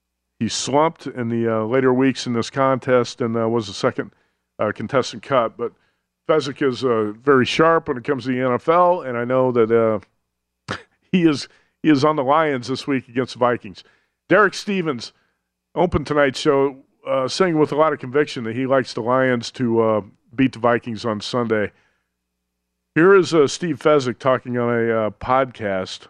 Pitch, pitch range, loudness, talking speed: 125 Hz, 115-145 Hz, -19 LUFS, 185 wpm